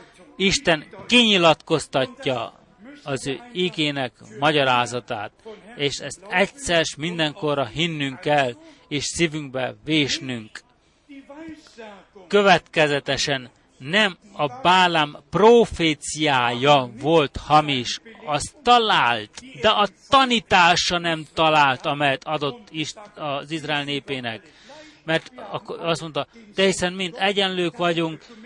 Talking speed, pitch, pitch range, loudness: 90 wpm, 160 Hz, 140-195 Hz, -21 LUFS